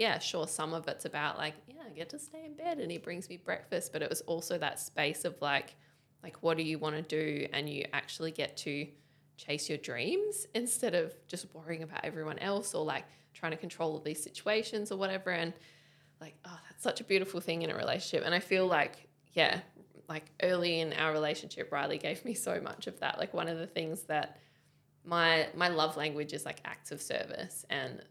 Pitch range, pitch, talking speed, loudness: 150-180 Hz, 165 Hz, 220 wpm, -35 LUFS